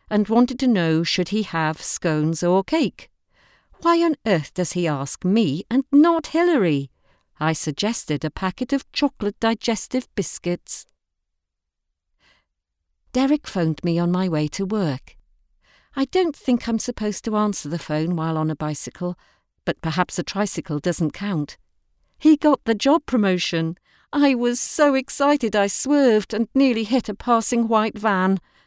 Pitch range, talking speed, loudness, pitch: 160-245 Hz, 155 wpm, -21 LUFS, 200 Hz